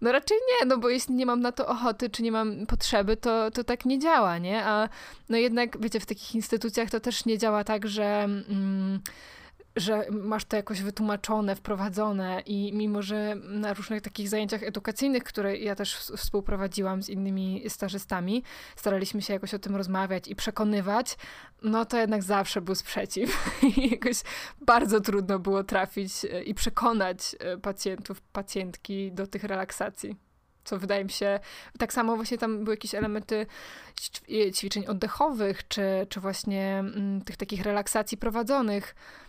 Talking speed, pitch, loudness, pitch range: 155 wpm, 210 Hz, -29 LUFS, 200-230 Hz